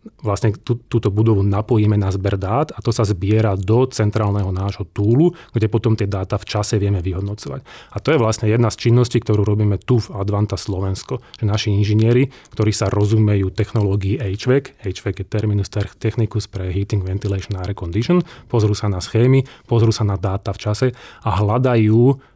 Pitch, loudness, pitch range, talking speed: 105 Hz, -19 LUFS, 100-115 Hz, 175 wpm